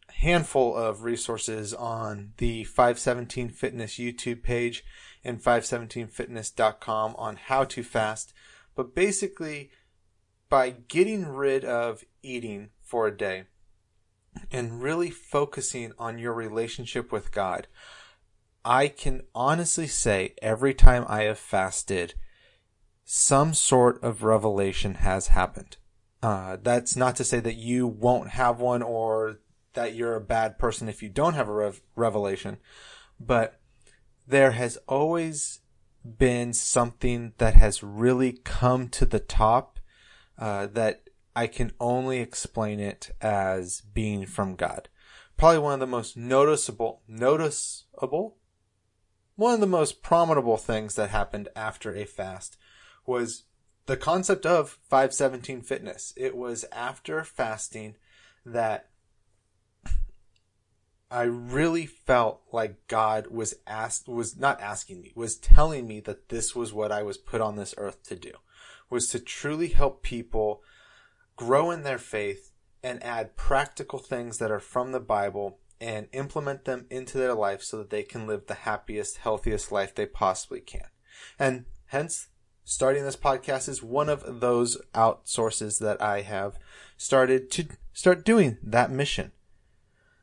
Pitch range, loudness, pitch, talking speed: 105-130 Hz, -27 LUFS, 120 Hz, 135 wpm